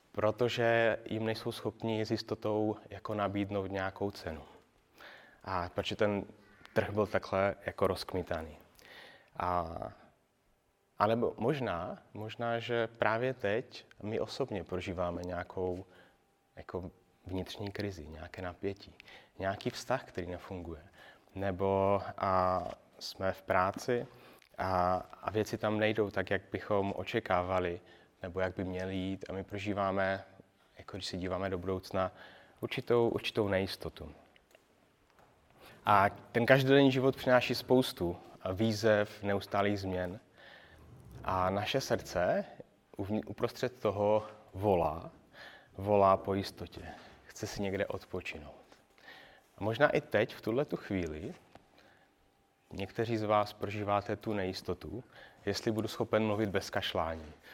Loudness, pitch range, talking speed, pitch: -34 LUFS, 95-110 Hz, 115 wpm, 100 Hz